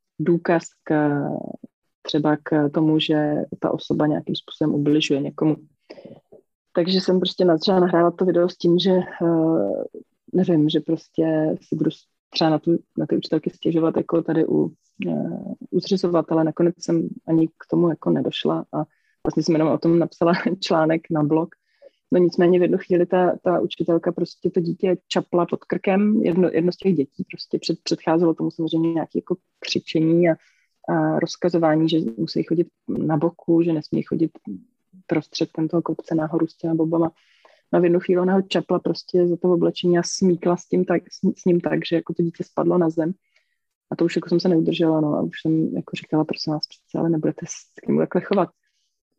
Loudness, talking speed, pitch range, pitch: -21 LUFS, 185 wpm, 160-180 Hz, 170 Hz